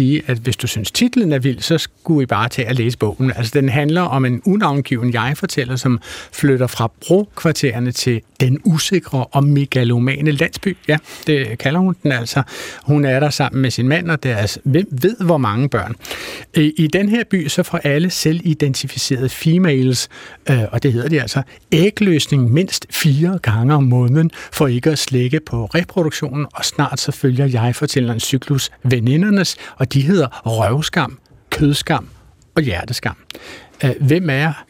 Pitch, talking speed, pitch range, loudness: 140 Hz, 170 wpm, 125-160 Hz, -17 LUFS